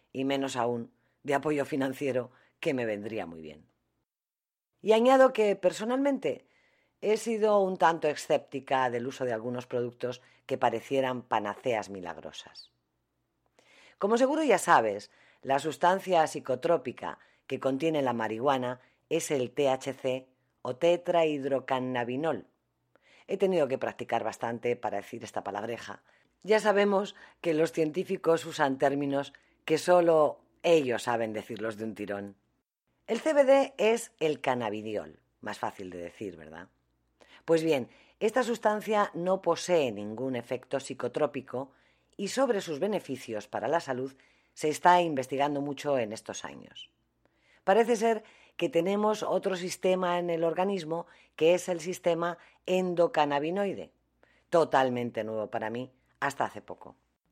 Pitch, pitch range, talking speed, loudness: 140 Hz, 120-180 Hz, 130 wpm, -29 LUFS